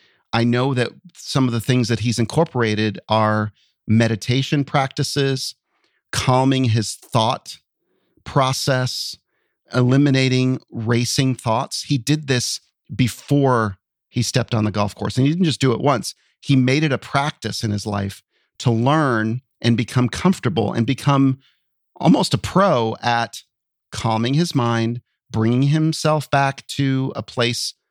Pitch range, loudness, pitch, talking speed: 115-135 Hz, -20 LUFS, 125 Hz, 140 wpm